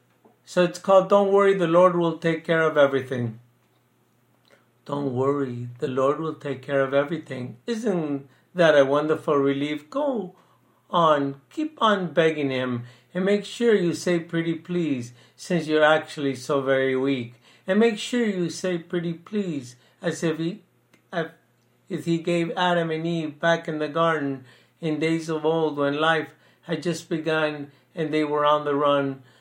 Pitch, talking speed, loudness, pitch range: 160 Hz, 165 wpm, -24 LUFS, 140-175 Hz